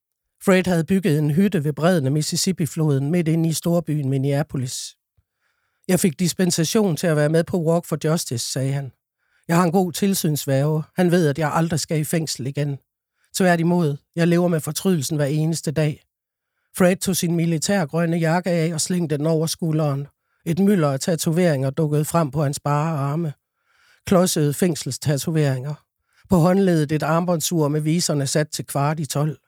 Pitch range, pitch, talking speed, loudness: 150-175 Hz, 160 Hz, 170 wpm, -21 LUFS